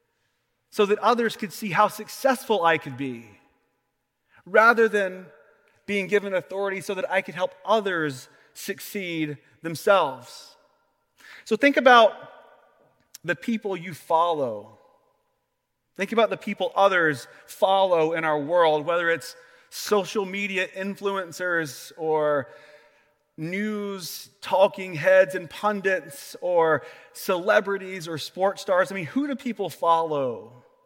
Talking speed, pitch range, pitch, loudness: 120 wpm, 165-215 Hz, 195 Hz, -24 LUFS